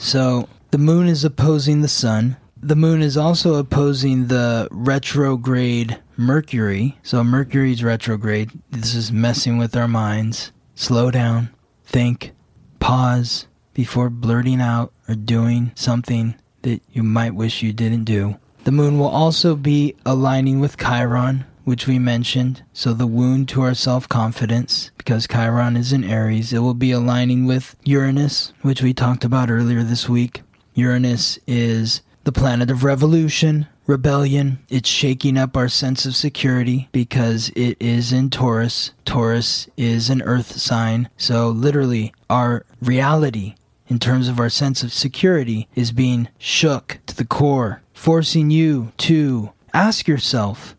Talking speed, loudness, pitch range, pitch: 145 wpm, -18 LUFS, 120-135 Hz, 125 Hz